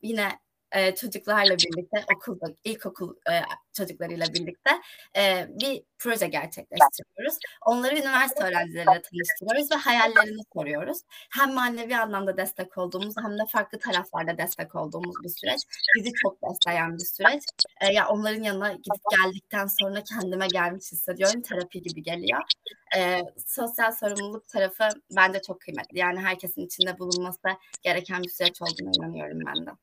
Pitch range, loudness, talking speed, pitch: 180-225 Hz, -25 LUFS, 140 wpm, 195 Hz